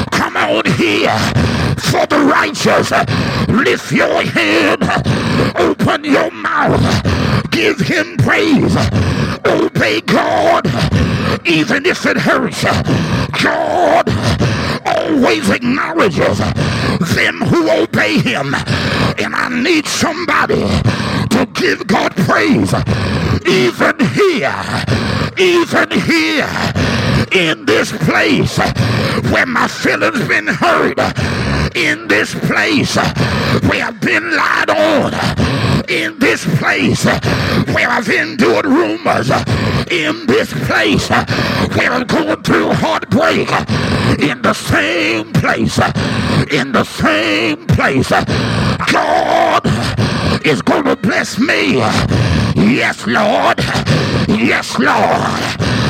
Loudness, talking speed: -13 LUFS, 95 wpm